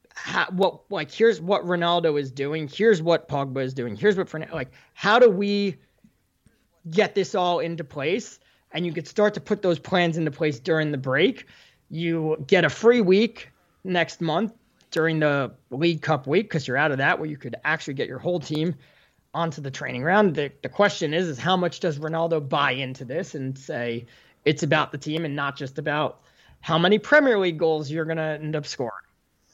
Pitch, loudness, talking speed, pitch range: 160 Hz, -24 LUFS, 200 wpm, 150-185 Hz